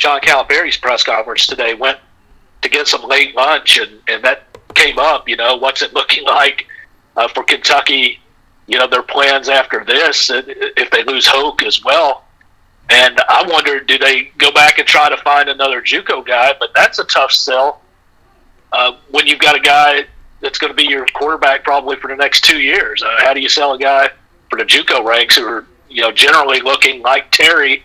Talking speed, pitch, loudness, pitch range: 200 wpm, 140 Hz, -10 LUFS, 135-150 Hz